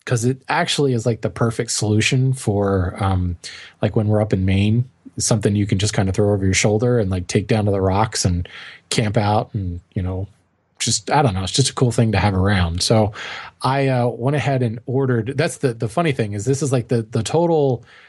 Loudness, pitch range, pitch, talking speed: -19 LUFS, 100-130 Hz, 115 Hz, 230 wpm